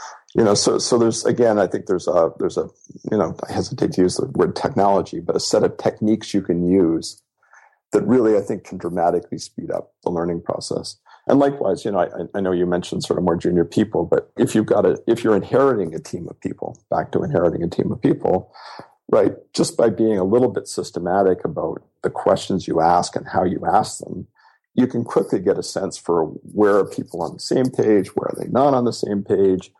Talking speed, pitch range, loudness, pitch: 230 wpm, 85-110 Hz, -20 LUFS, 95 Hz